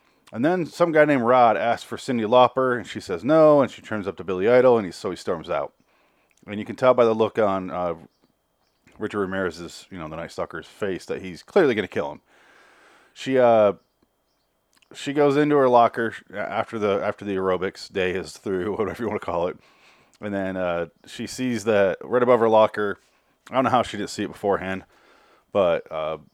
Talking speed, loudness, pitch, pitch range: 210 wpm, -22 LUFS, 110 Hz, 95-125 Hz